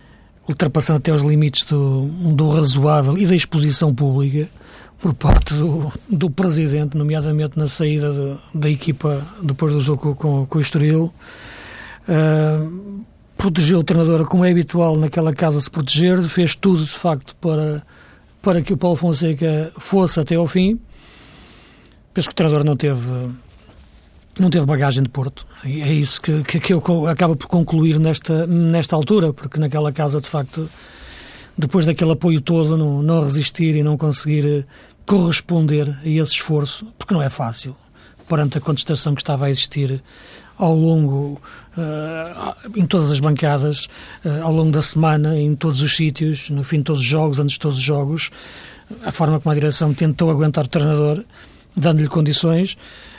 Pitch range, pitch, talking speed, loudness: 145-165 Hz, 155 Hz, 165 wpm, -17 LUFS